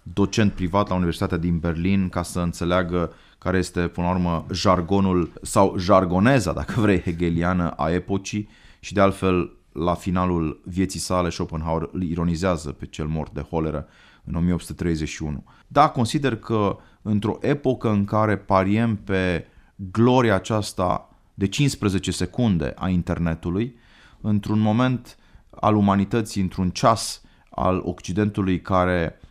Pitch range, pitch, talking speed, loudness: 85-105 Hz, 95 Hz, 130 wpm, -23 LUFS